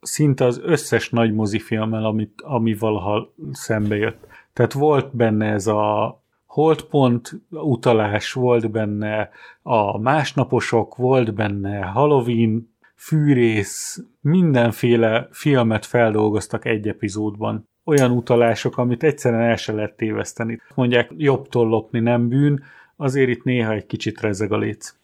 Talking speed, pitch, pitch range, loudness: 120 wpm, 115 Hz, 110-130 Hz, -20 LUFS